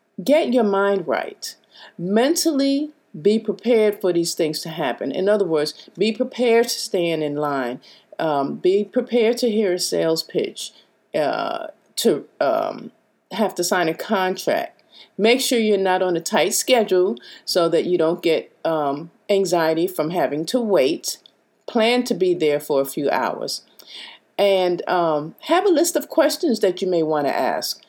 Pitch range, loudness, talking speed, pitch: 170-245 Hz, -20 LUFS, 165 wpm, 200 Hz